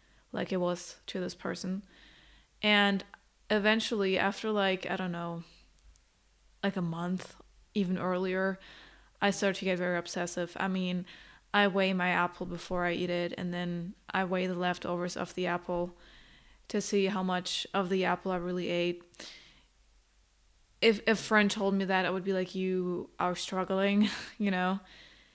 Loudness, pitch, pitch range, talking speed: -31 LUFS, 185 Hz, 175-195 Hz, 160 wpm